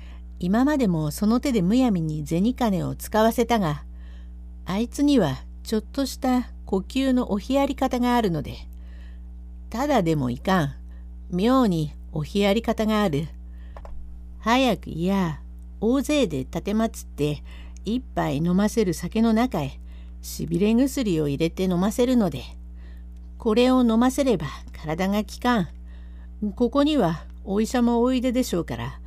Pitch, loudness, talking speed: 180 Hz, -23 LUFS, 265 characters per minute